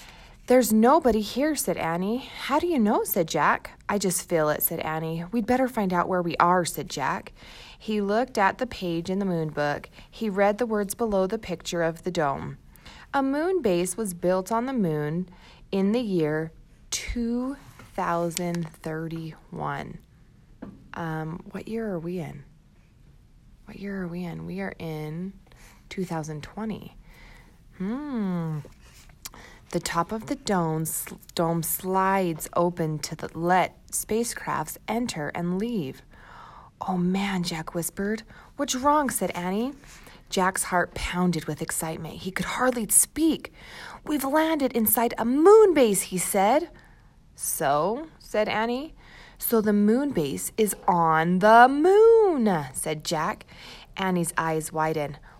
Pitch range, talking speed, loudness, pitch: 165-225 Hz, 140 wpm, -25 LUFS, 190 Hz